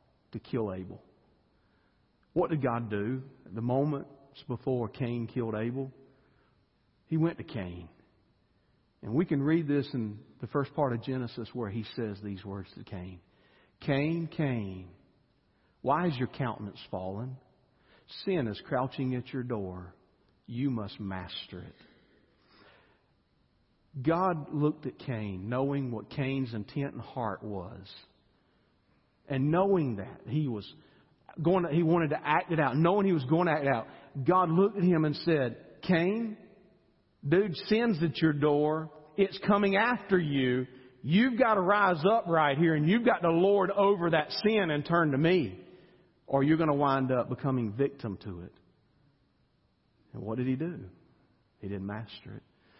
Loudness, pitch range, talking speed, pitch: -30 LUFS, 115-165 Hz, 155 wpm, 135 Hz